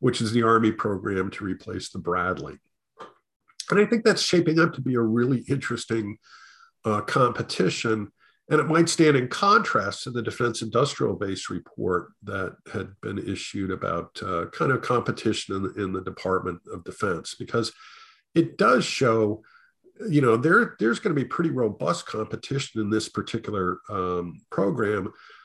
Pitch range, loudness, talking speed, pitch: 100-135 Hz, -25 LUFS, 165 wpm, 115 Hz